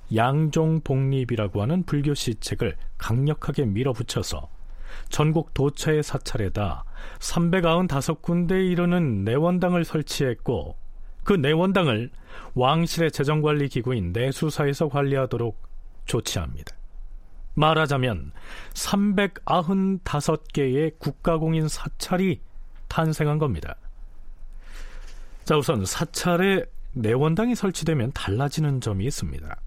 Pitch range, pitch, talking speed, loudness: 110-160 Hz, 145 Hz, 240 characters per minute, -24 LUFS